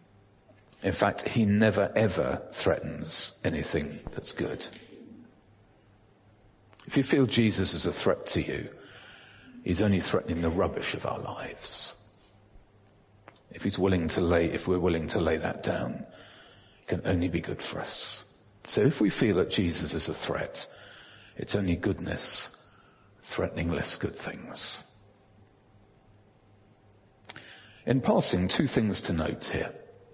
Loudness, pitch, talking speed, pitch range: -29 LUFS, 100 Hz, 135 wpm, 90-105 Hz